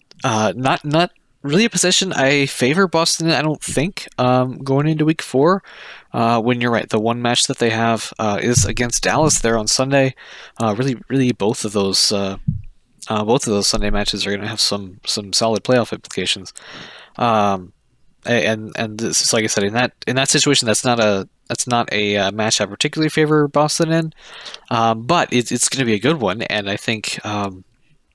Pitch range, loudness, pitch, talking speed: 110-140 Hz, -17 LUFS, 120 Hz, 205 wpm